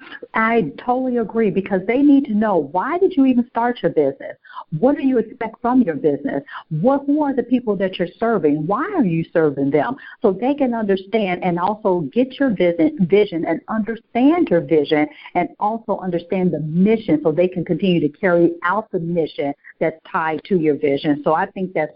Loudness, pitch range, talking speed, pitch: -19 LUFS, 165-235 Hz, 195 wpm, 195 Hz